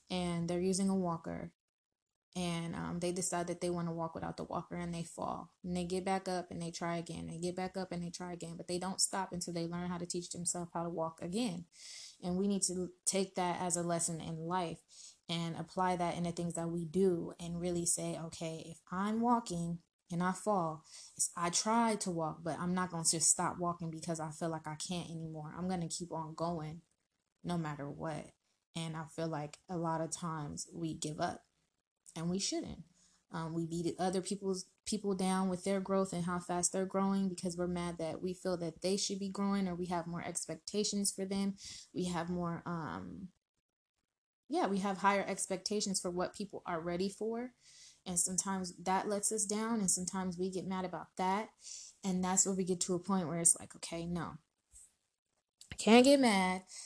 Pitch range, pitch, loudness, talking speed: 170-190 Hz, 175 Hz, -36 LUFS, 215 wpm